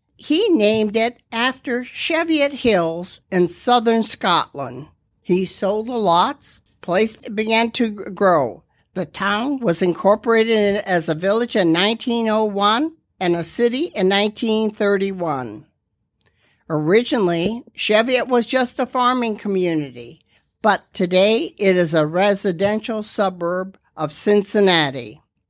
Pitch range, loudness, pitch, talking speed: 180-230 Hz, -19 LUFS, 205 Hz, 110 wpm